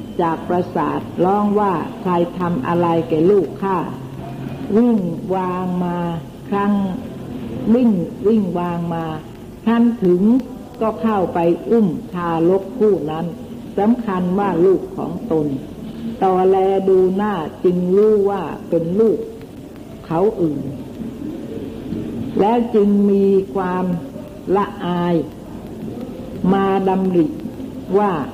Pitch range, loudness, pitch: 175-210 Hz, -18 LUFS, 190 Hz